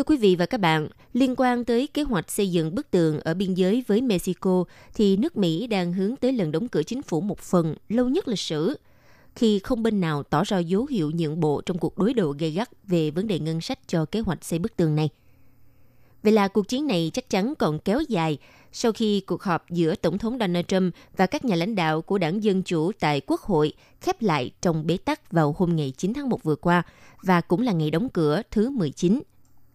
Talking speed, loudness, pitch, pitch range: 235 wpm, -24 LUFS, 185 Hz, 160-215 Hz